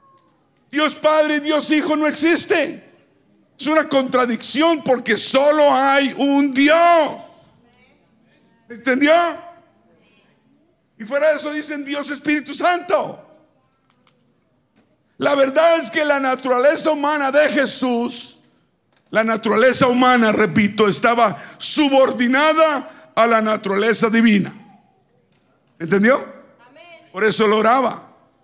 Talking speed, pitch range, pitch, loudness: 100 wpm, 235-305 Hz, 275 Hz, -16 LUFS